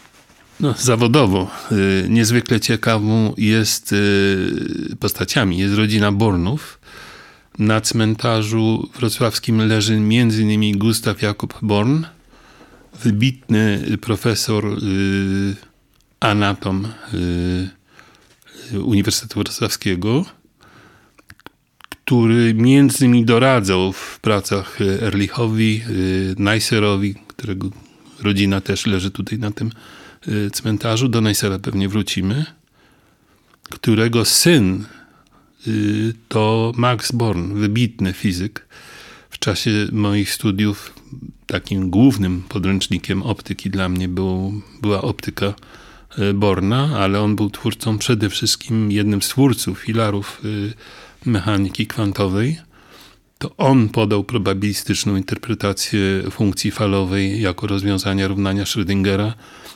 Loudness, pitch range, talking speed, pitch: -18 LUFS, 100-115 Hz, 85 wpm, 105 Hz